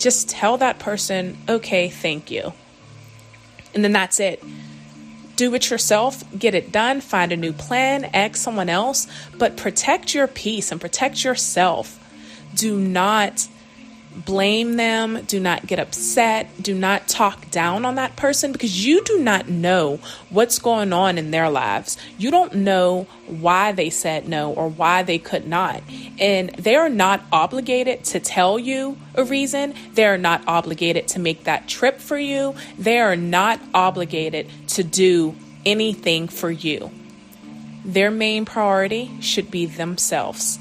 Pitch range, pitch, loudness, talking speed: 170-235 Hz, 195 Hz, -19 LUFS, 155 wpm